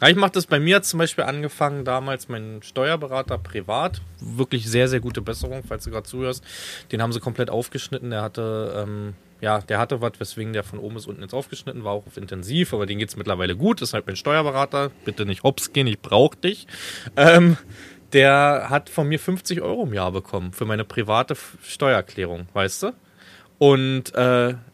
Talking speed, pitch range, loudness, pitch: 190 wpm, 105-140 Hz, -22 LUFS, 120 Hz